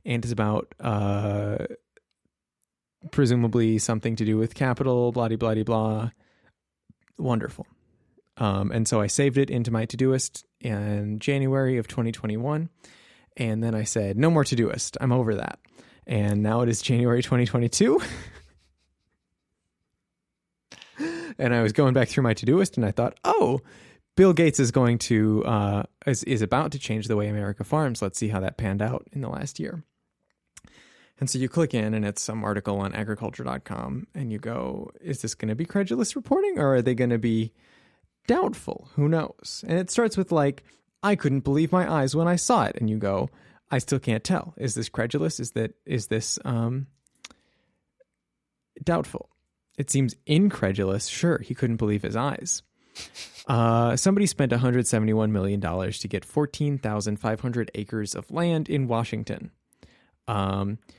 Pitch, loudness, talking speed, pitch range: 115 Hz, -25 LUFS, 170 wpm, 105-140 Hz